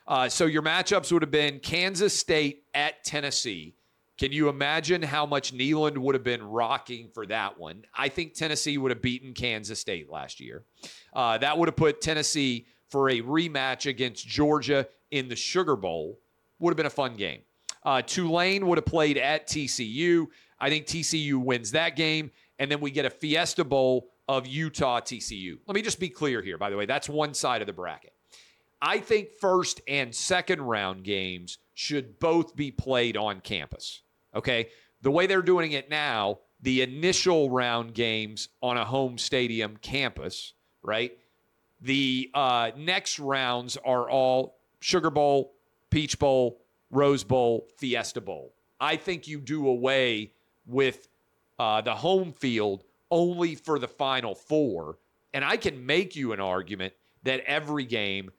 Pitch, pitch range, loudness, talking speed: 135 Hz, 120-155 Hz, -27 LUFS, 165 wpm